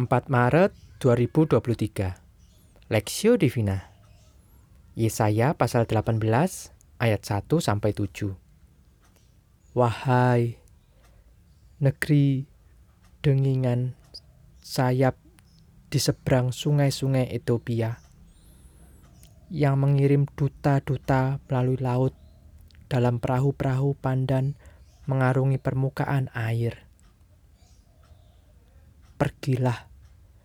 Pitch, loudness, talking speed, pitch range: 120 Hz, -25 LUFS, 65 wpm, 95-135 Hz